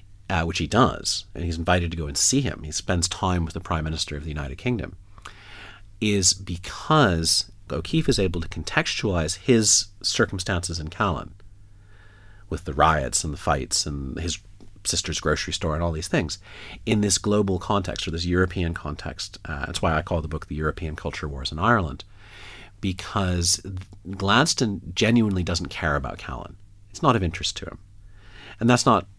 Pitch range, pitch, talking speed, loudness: 80-100 Hz, 95 Hz, 175 wpm, -24 LUFS